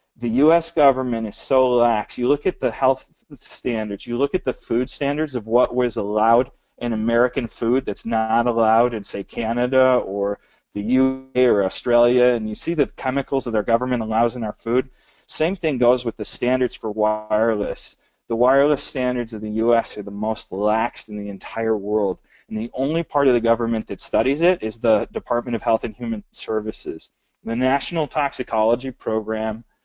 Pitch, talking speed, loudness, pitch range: 120 Hz, 185 wpm, -21 LUFS, 110-130 Hz